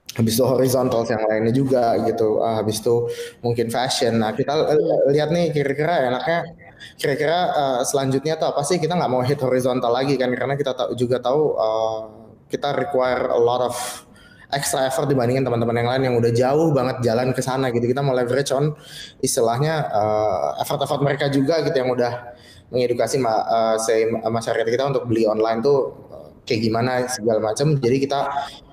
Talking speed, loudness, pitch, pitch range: 180 wpm, -20 LUFS, 125 Hz, 115-140 Hz